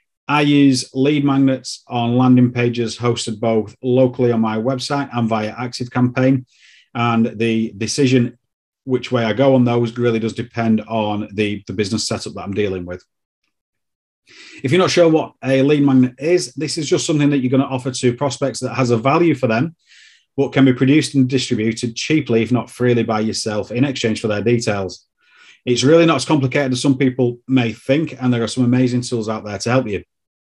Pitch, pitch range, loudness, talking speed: 125 Hz, 115-135 Hz, -17 LUFS, 200 wpm